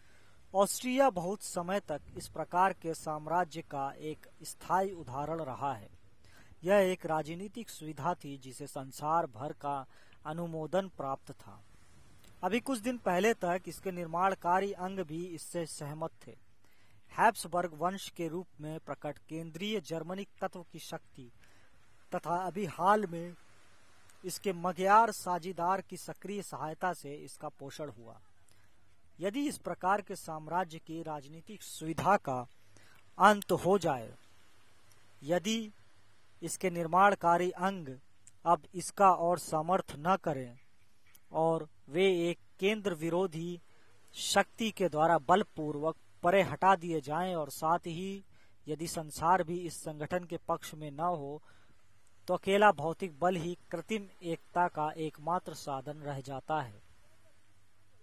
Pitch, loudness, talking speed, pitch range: 165 Hz, -33 LUFS, 130 wpm, 135-180 Hz